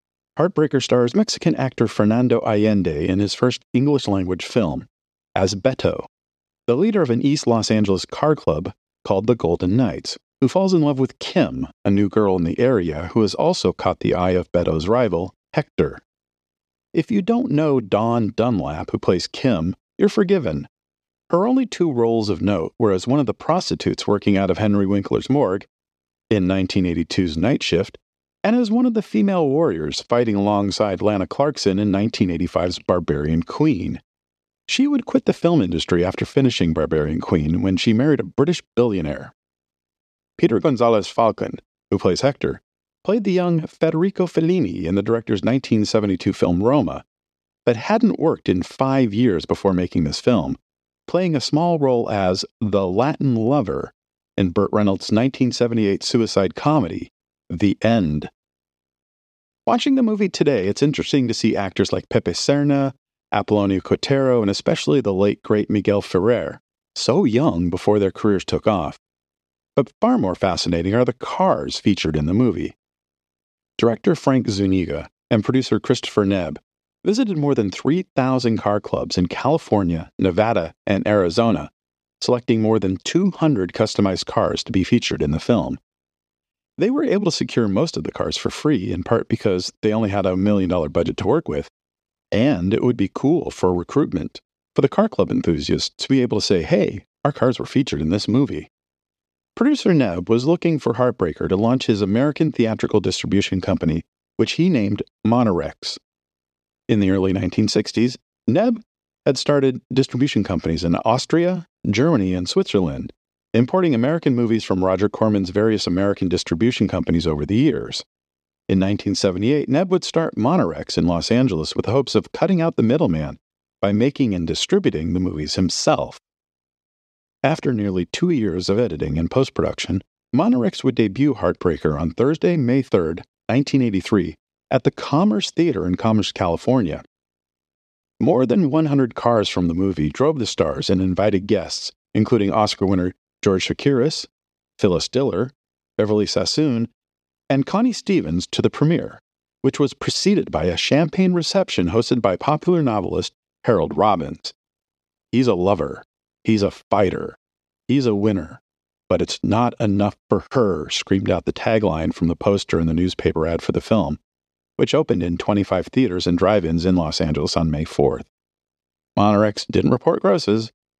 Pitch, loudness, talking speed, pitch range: 105 Hz, -20 LUFS, 160 wpm, 90-135 Hz